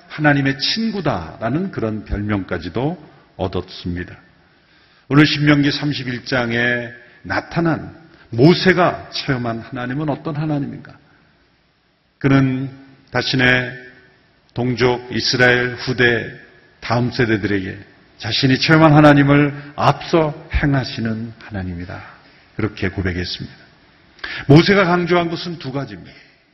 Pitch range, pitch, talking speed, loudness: 115-150 Hz, 130 Hz, 255 characters per minute, -17 LUFS